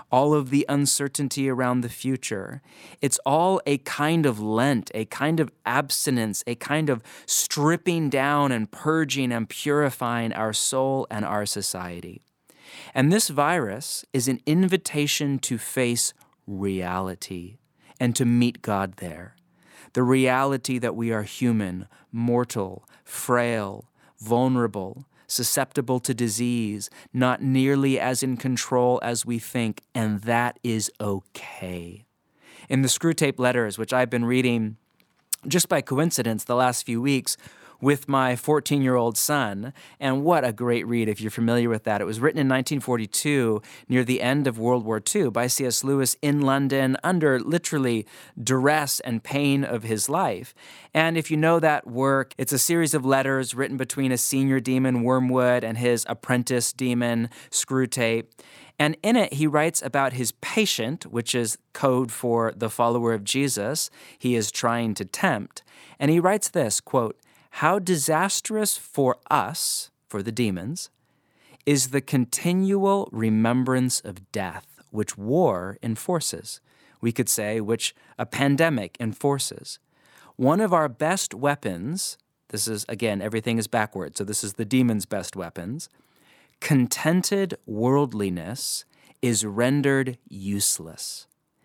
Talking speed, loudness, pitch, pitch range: 145 wpm, -24 LUFS, 125 Hz, 115-140 Hz